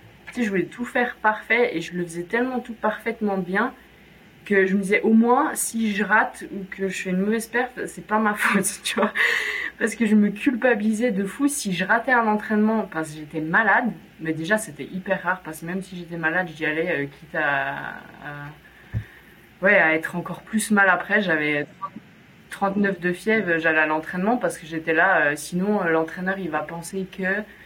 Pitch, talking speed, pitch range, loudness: 195 Hz, 210 wpm, 170-215 Hz, -22 LUFS